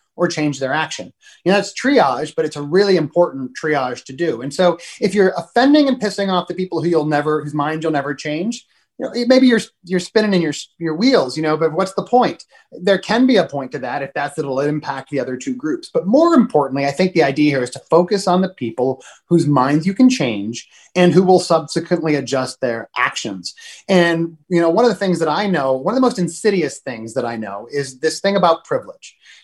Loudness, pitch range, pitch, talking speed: -17 LUFS, 145-200 Hz, 170 Hz, 235 wpm